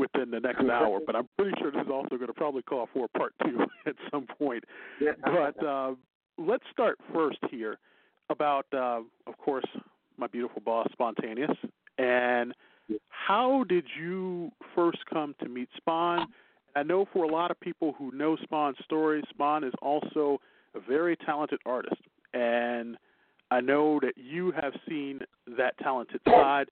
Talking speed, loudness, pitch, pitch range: 160 wpm, -30 LUFS, 145 Hz, 125-165 Hz